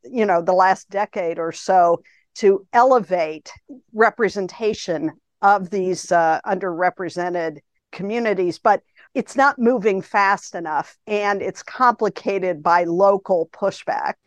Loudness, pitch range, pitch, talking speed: -20 LUFS, 175-220 Hz, 195 Hz, 115 wpm